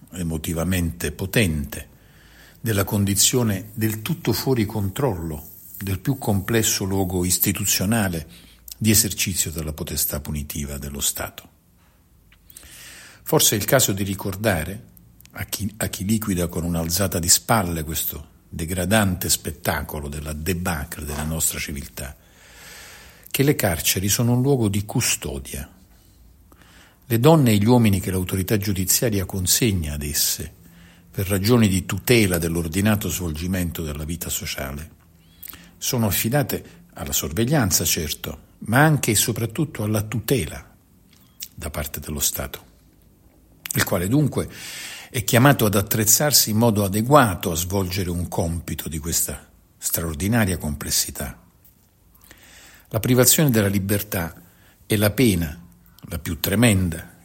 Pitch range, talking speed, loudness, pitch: 85-110 Hz, 120 wpm, -21 LUFS, 95 Hz